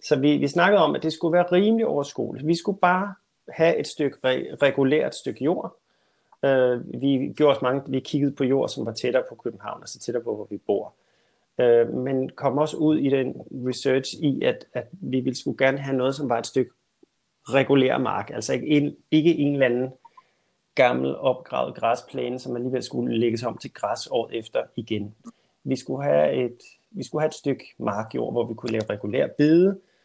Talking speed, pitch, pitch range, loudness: 200 wpm, 135 Hz, 125-150 Hz, -24 LUFS